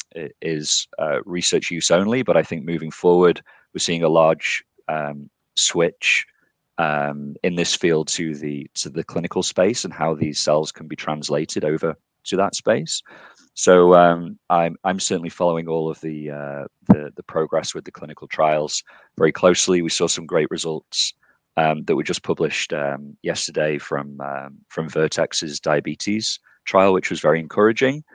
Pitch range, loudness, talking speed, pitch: 75-85 Hz, -20 LUFS, 165 wpm, 80 Hz